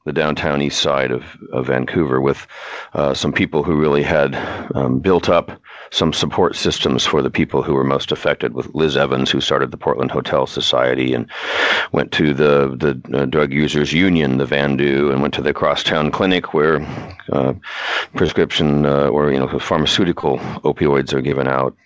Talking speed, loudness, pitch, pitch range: 180 wpm, -17 LUFS, 70 Hz, 65-75 Hz